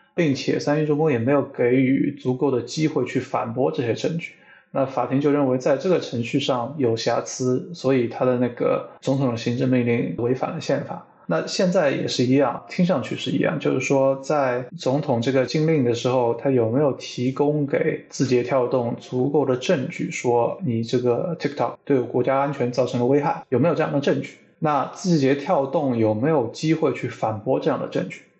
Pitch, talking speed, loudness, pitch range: 135 Hz, 305 characters per minute, -22 LUFS, 125-145 Hz